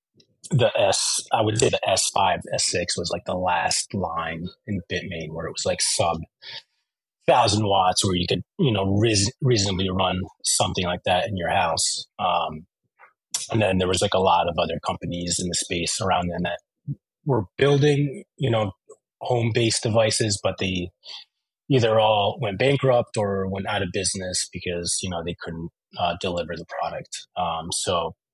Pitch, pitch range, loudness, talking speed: 95 Hz, 90-115 Hz, -23 LUFS, 175 wpm